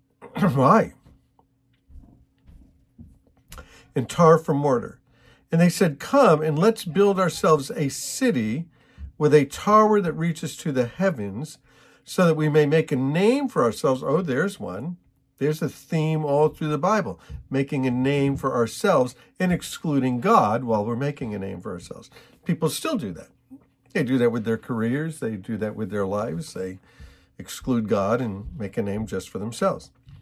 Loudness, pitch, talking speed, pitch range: -23 LUFS, 145 Hz, 165 wpm, 120-165 Hz